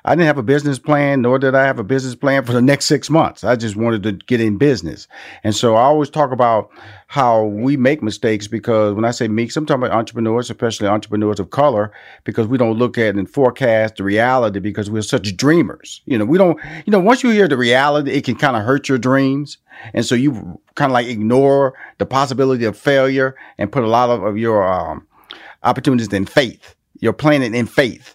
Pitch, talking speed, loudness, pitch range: 125 Hz, 225 wpm, -16 LUFS, 110-140 Hz